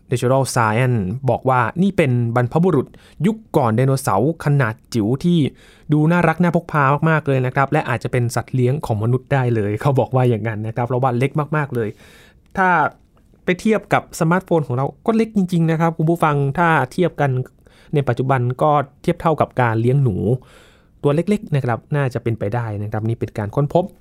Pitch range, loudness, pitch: 120-160 Hz, -18 LUFS, 135 Hz